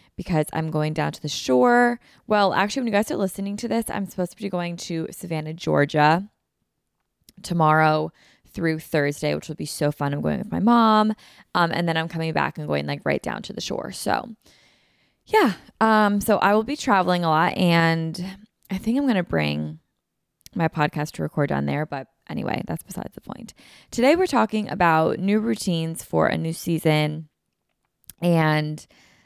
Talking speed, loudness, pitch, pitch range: 185 wpm, -22 LUFS, 170 Hz, 155-205 Hz